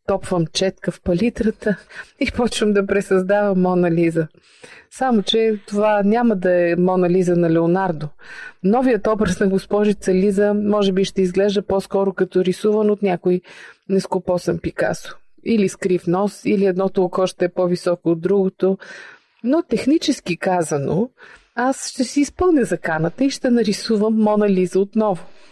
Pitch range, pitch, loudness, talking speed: 185-215 Hz, 195 Hz, -19 LUFS, 145 wpm